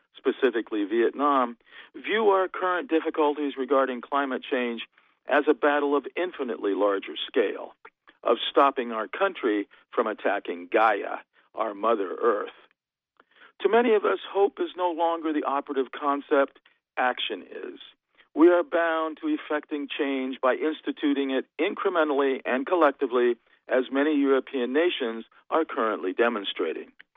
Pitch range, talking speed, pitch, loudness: 135-190 Hz, 130 wpm, 150 Hz, -26 LUFS